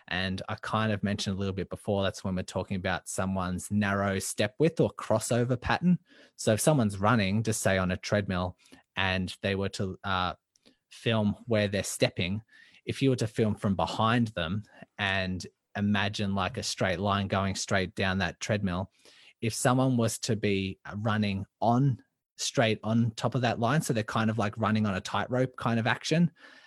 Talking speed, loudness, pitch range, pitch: 185 wpm, -29 LUFS, 95-115 Hz, 105 Hz